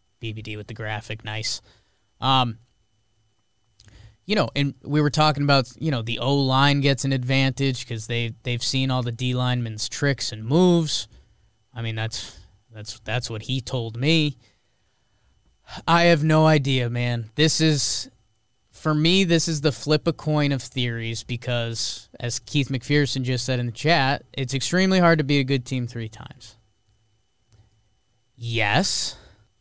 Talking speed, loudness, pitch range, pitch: 160 wpm, -22 LUFS, 110-140 Hz, 125 Hz